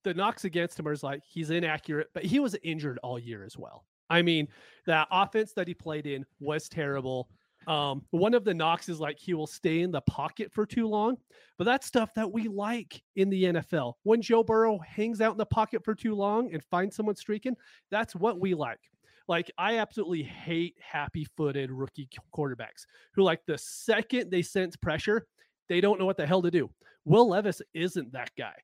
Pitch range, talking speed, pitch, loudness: 155-215 Hz, 205 wpm, 175 Hz, -30 LUFS